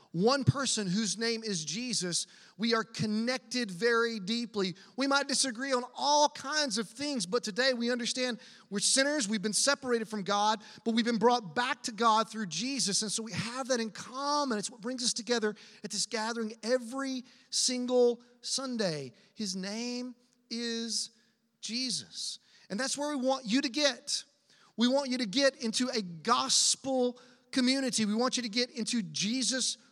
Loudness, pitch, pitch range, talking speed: -30 LUFS, 235 Hz, 220-255 Hz, 170 wpm